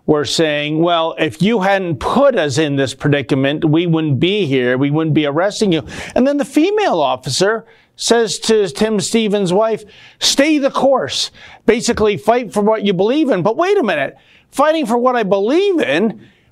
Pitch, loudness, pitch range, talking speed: 205 Hz, -15 LUFS, 160-240 Hz, 180 wpm